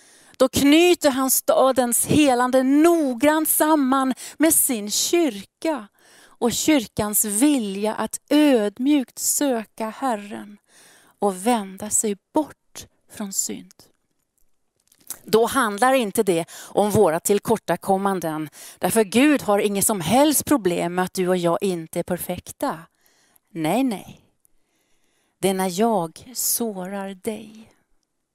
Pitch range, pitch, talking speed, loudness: 195-265 Hz, 225 Hz, 110 wpm, -20 LUFS